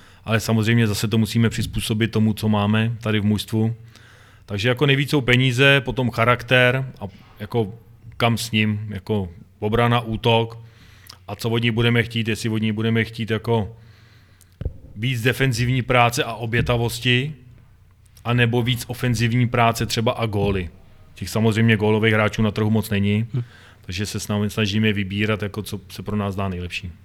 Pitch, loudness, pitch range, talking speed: 110 Hz, -20 LUFS, 105-120 Hz, 155 wpm